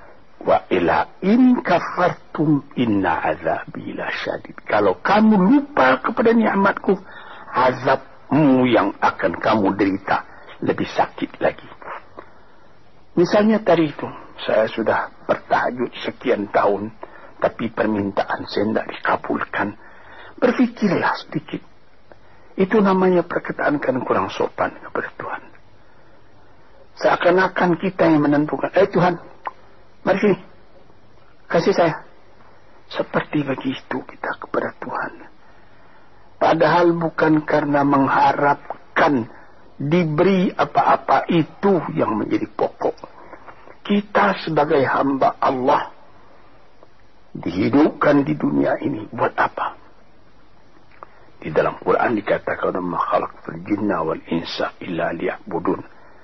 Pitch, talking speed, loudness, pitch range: 175 Hz, 95 wpm, -19 LUFS, 145-205 Hz